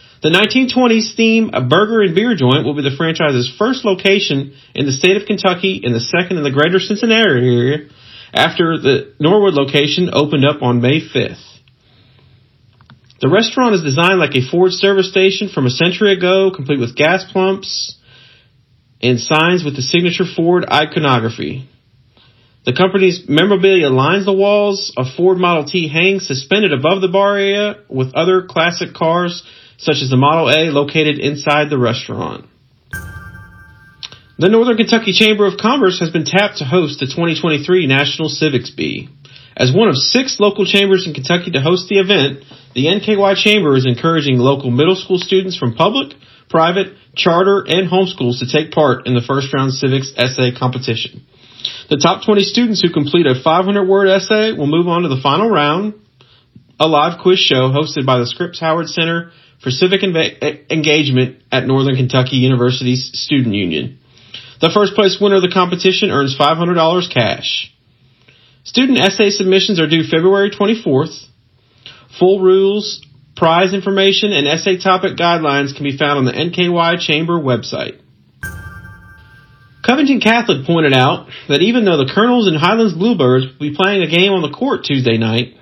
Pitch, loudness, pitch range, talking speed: 155 Hz, -13 LUFS, 130-190 Hz, 165 wpm